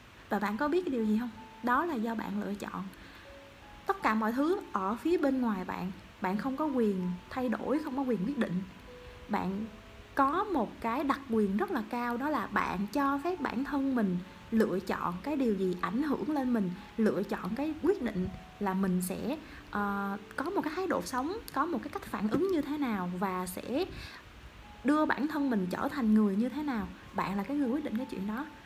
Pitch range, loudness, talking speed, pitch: 200-285 Hz, -32 LUFS, 220 wpm, 235 Hz